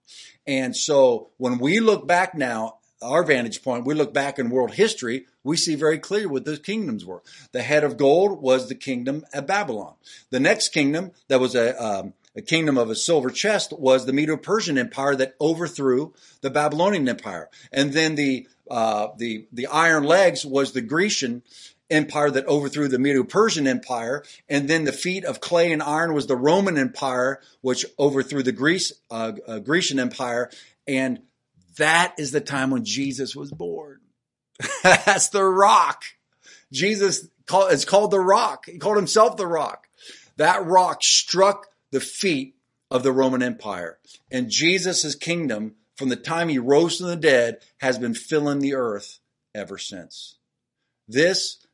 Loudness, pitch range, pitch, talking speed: -21 LUFS, 130-175 Hz, 145 Hz, 165 wpm